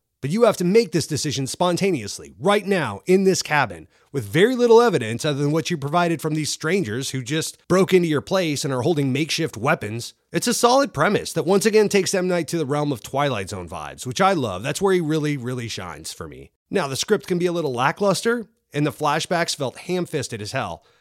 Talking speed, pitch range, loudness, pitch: 225 wpm, 135-185 Hz, -21 LUFS, 160 Hz